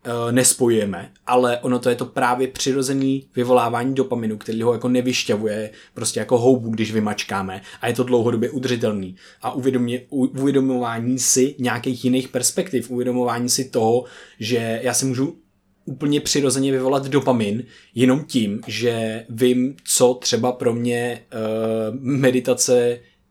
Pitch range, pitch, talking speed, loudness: 115-130 Hz, 125 Hz, 135 wpm, -20 LUFS